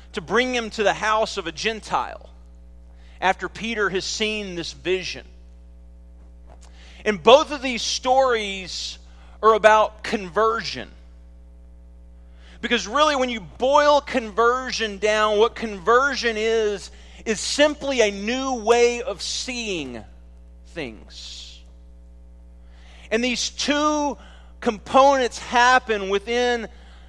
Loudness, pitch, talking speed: -21 LUFS, 210 Hz, 105 wpm